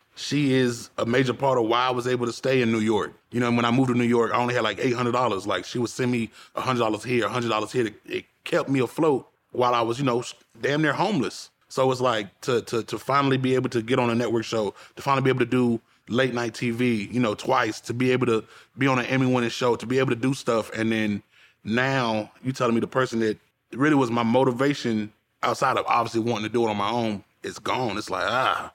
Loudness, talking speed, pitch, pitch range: -24 LUFS, 255 wpm, 120 Hz, 115-130 Hz